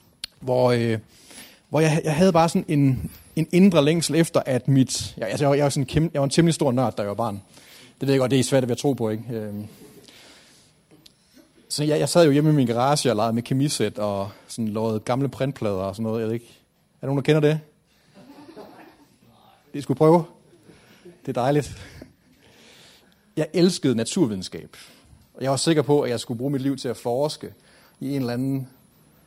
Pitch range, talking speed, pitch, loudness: 120-155 Hz, 205 wpm, 140 Hz, -22 LUFS